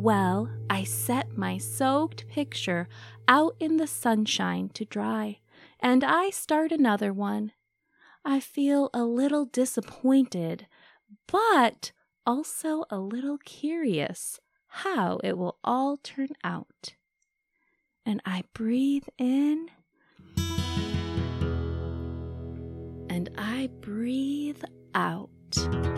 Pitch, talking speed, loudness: 230 Hz, 95 wpm, -28 LUFS